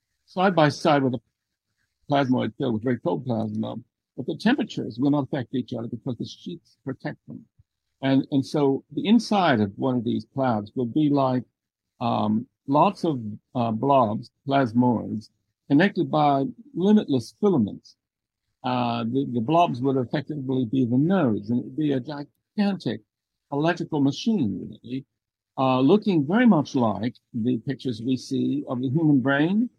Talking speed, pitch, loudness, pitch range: 155 wpm, 130 Hz, -24 LUFS, 115-150 Hz